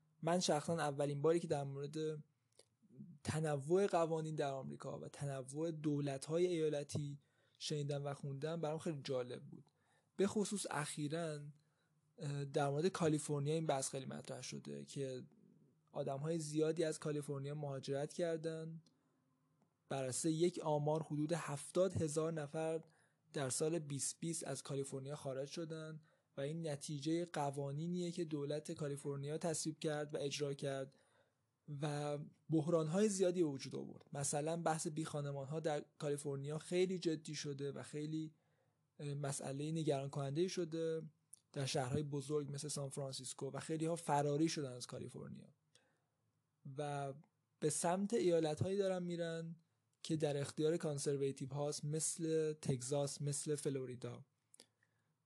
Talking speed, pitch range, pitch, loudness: 130 wpm, 140-160 Hz, 150 Hz, -41 LUFS